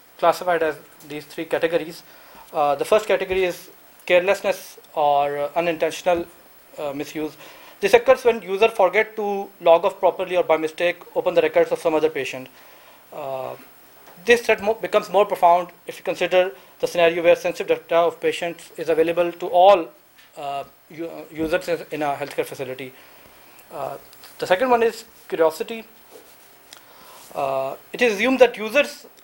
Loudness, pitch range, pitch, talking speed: -21 LUFS, 160-215 Hz, 175 Hz, 150 wpm